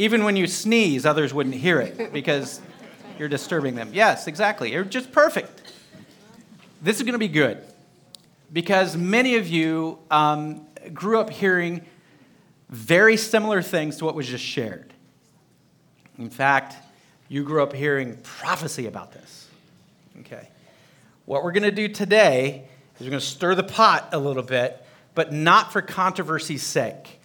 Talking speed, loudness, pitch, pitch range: 150 wpm, -22 LUFS, 165 Hz, 140-205 Hz